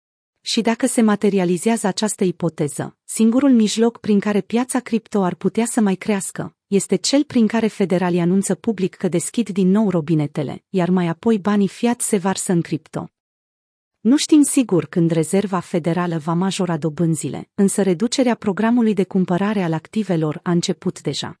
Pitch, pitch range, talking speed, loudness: 195 Hz, 175-220 Hz, 160 wpm, -19 LUFS